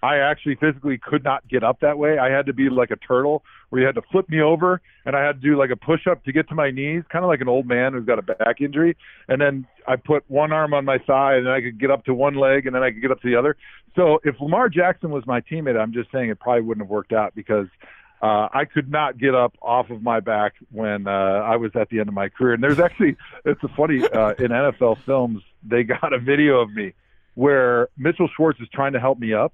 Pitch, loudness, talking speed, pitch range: 135 Hz, -20 LUFS, 275 wpm, 120-150 Hz